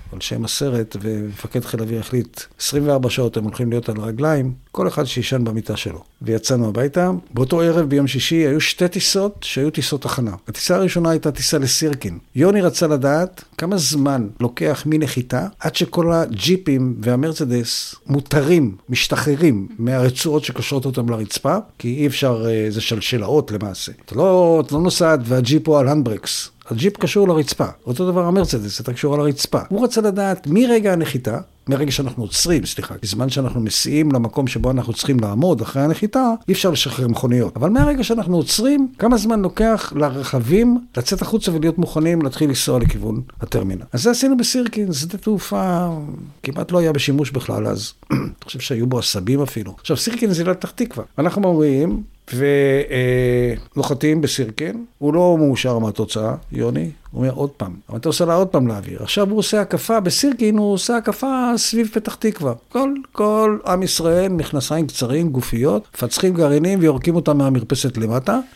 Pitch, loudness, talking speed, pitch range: 145 Hz, -18 LUFS, 160 wpm, 125-180 Hz